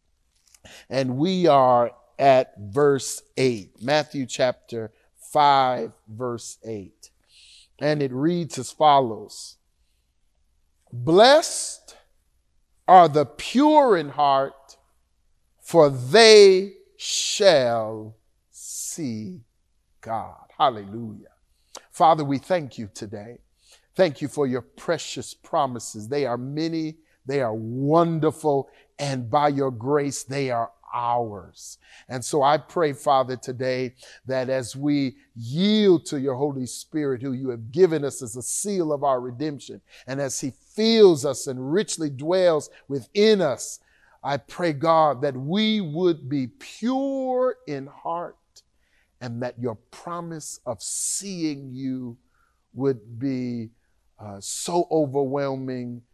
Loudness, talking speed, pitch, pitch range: -22 LUFS, 115 wpm, 135 Hz, 120-155 Hz